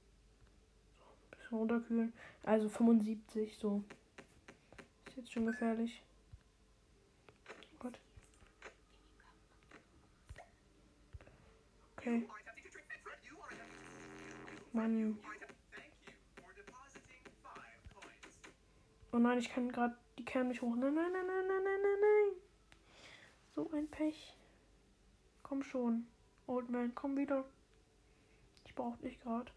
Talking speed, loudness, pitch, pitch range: 85 wpm, -38 LUFS, 245 Hz, 230-280 Hz